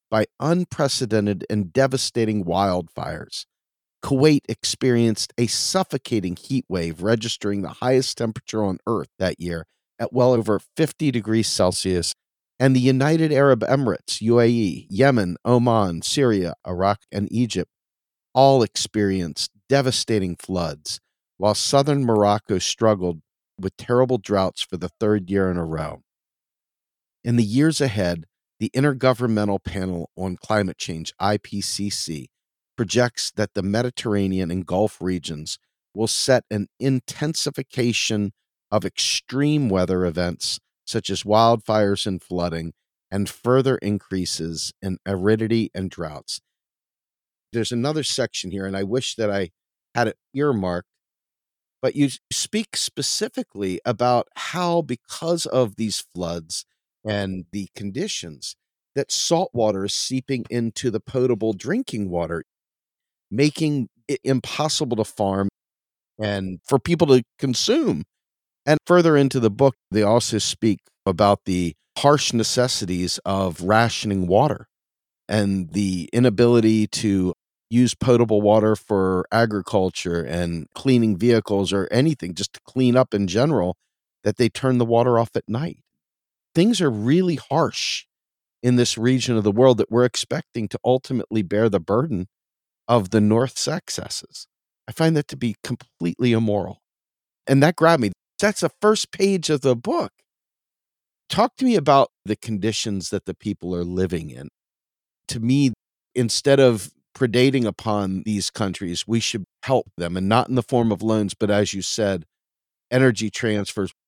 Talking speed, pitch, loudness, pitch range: 135 wpm, 110 Hz, -21 LUFS, 95-130 Hz